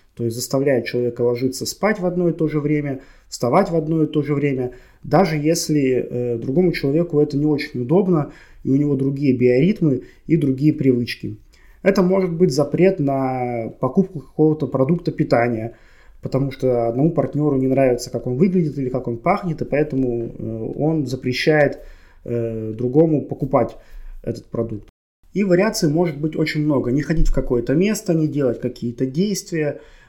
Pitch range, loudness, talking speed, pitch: 125-160 Hz, -20 LUFS, 165 wpm, 140 Hz